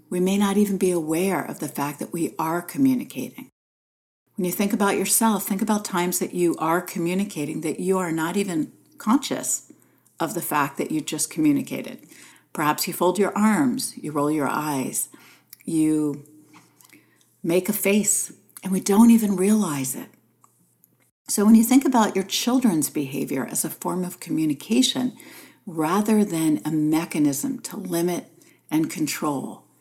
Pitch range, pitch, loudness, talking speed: 160-215 Hz, 185 Hz, -23 LUFS, 155 wpm